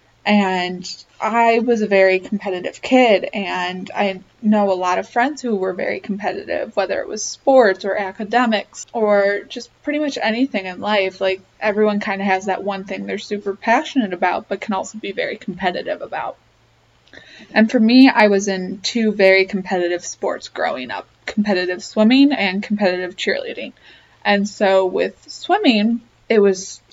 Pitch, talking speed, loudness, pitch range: 200 Hz, 165 wpm, -18 LUFS, 190-225 Hz